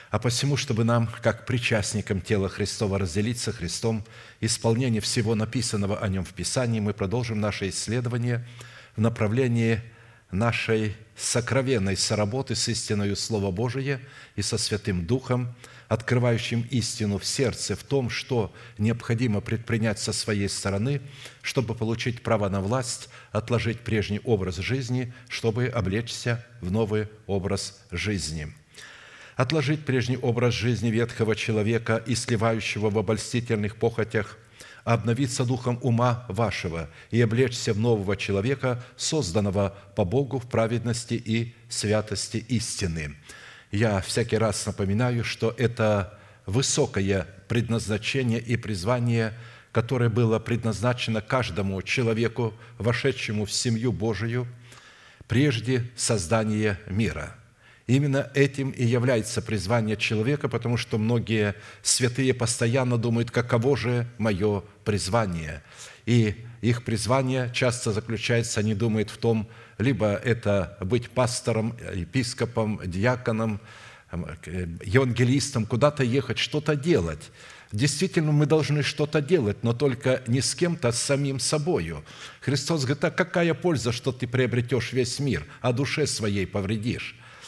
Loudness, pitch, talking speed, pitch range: -26 LUFS, 115 Hz, 120 wpm, 105-125 Hz